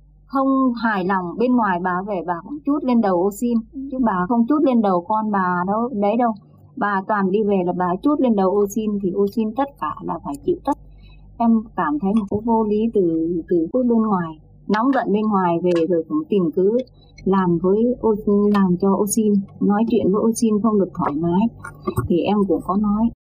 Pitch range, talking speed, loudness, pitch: 185-230 Hz, 225 wpm, -20 LUFS, 205 Hz